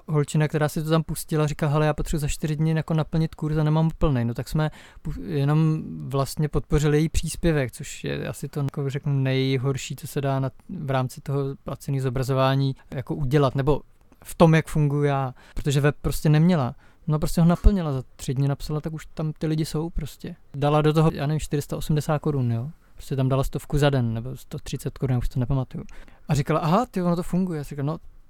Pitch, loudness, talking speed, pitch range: 150 Hz, -24 LUFS, 215 wpm, 135-160 Hz